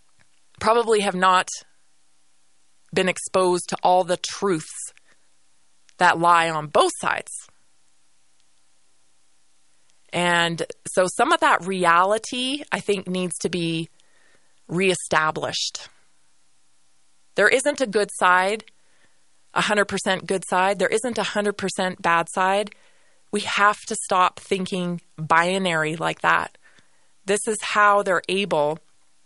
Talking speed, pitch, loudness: 110 wpm, 175 Hz, -21 LUFS